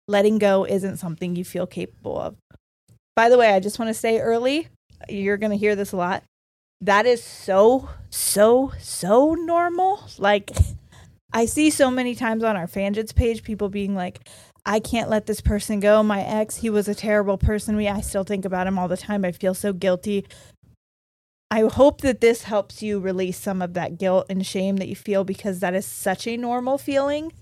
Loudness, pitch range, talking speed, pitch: -22 LUFS, 190-230 Hz, 200 wpm, 205 Hz